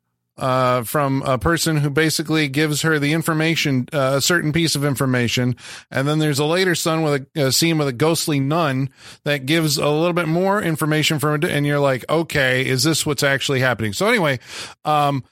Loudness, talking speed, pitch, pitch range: -19 LUFS, 200 wpm, 150 Hz, 135-160 Hz